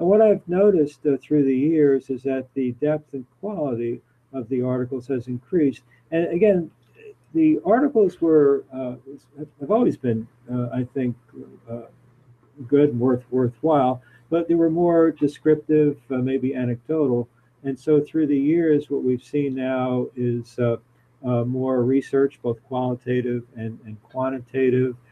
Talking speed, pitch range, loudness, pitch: 150 wpm, 125-150 Hz, -22 LUFS, 130 Hz